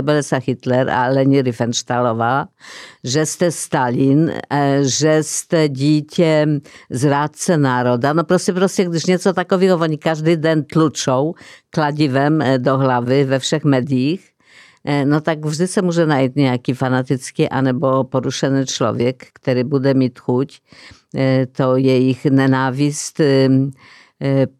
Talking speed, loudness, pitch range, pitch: 110 wpm, -17 LUFS, 130-155 Hz, 140 Hz